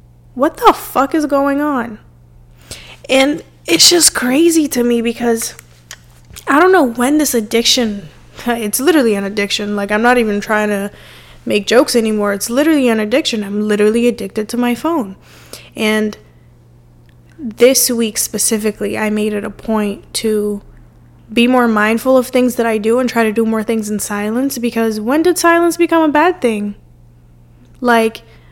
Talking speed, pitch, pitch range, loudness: 160 wpm, 225 Hz, 205-255 Hz, -14 LUFS